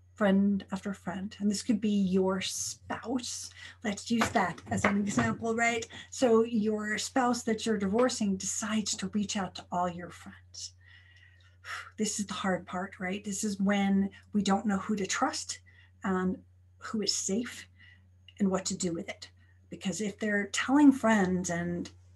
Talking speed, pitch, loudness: 165 wpm, 195 Hz, -30 LUFS